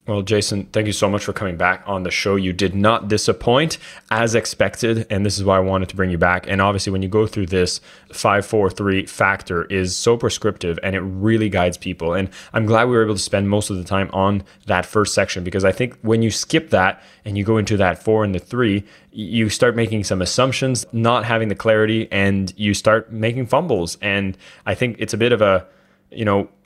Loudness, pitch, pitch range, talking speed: -19 LUFS, 100 Hz, 95-110 Hz, 225 wpm